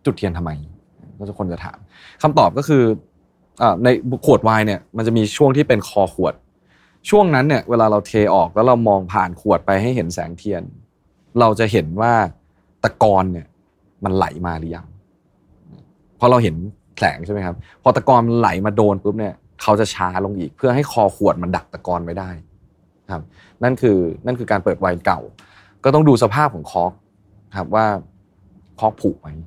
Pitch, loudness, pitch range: 105 Hz, -17 LUFS, 90-115 Hz